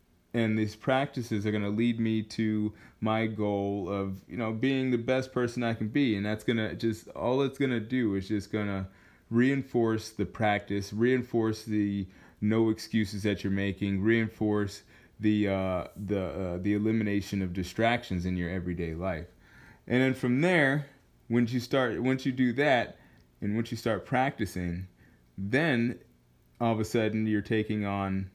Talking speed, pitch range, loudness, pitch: 175 wpm, 100-120 Hz, -30 LUFS, 110 Hz